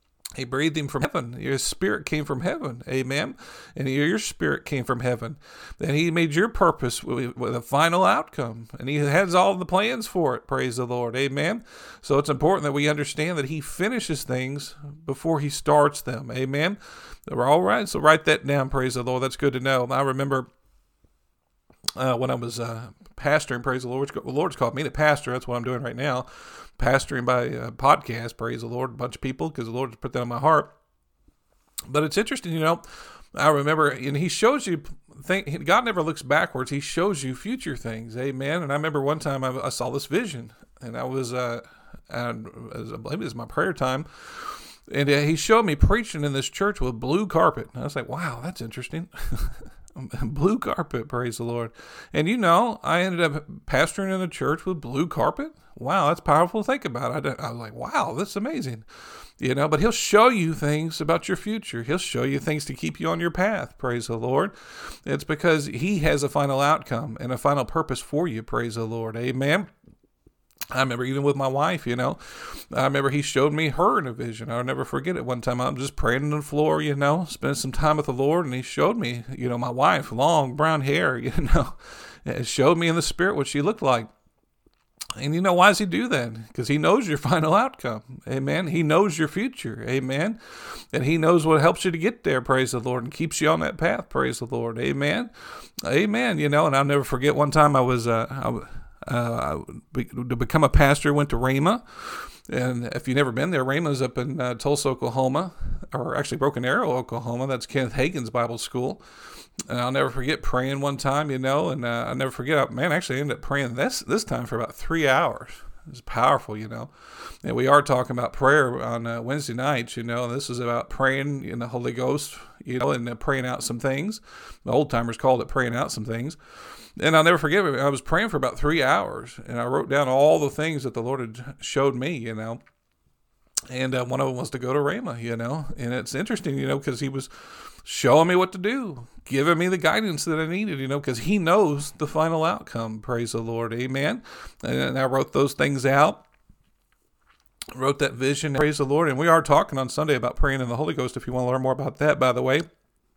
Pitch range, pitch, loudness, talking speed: 125-155 Hz, 140 Hz, -24 LUFS, 220 wpm